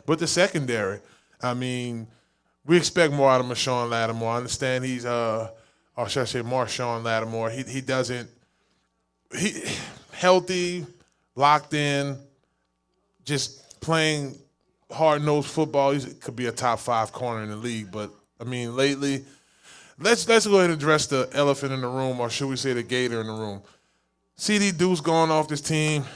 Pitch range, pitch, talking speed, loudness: 120-150 Hz, 130 Hz, 170 wpm, -24 LUFS